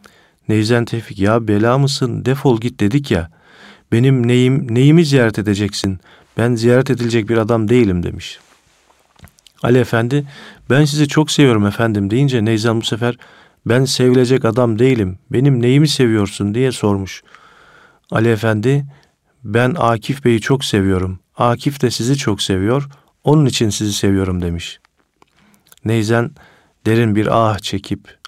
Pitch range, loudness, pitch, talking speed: 110-130 Hz, -15 LUFS, 120 Hz, 135 wpm